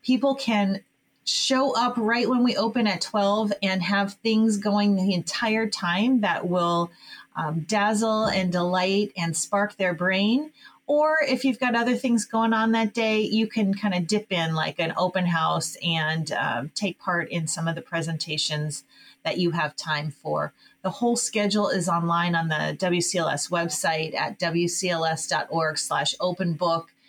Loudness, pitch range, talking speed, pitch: -24 LUFS, 170-220 Hz, 160 wpm, 190 Hz